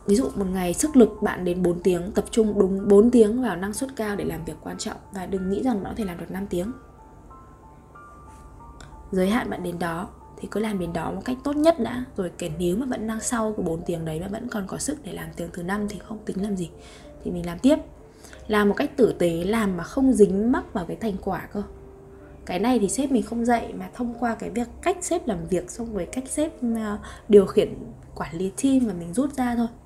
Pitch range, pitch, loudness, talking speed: 185-240 Hz, 210 Hz, -24 LUFS, 250 wpm